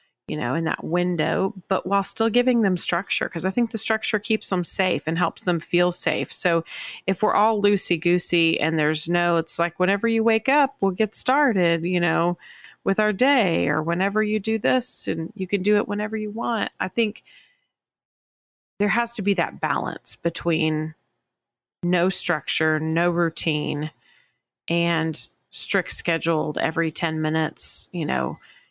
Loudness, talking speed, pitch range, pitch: -23 LUFS, 170 wpm, 165-215 Hz, 180 Hz